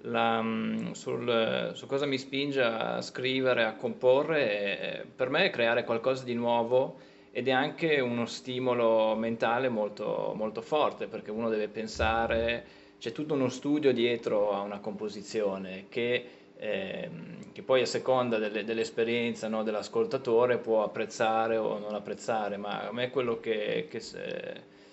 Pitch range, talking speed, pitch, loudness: 110-130 Hz, 150 wpm, 115 Hz, -30 LUFS